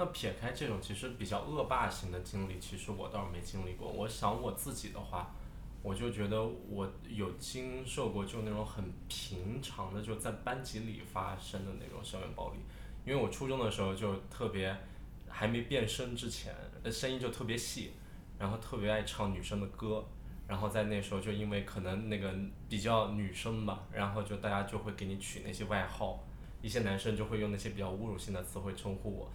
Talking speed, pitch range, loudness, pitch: 300 characters per minute, 95-110 Hz, -39 LUFS, 105 Hz